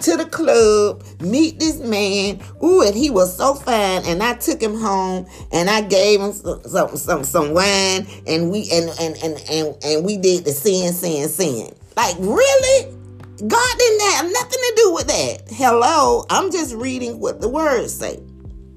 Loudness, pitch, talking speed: -17 LUFS, 210 Hz, 180 wpm